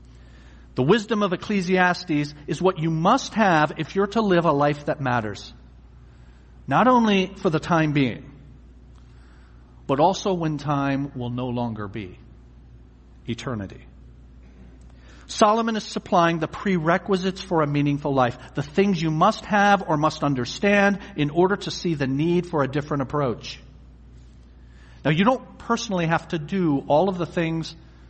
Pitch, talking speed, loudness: 145 Hz, 150 wpm, -22 LUFS